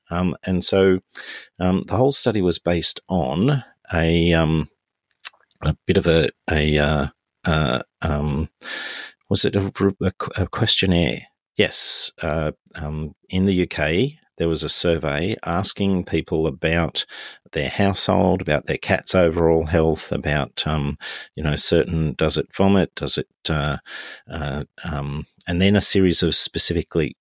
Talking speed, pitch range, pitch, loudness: 140 wpm, 80-95 Hz, 85 Hz, -19 LUFS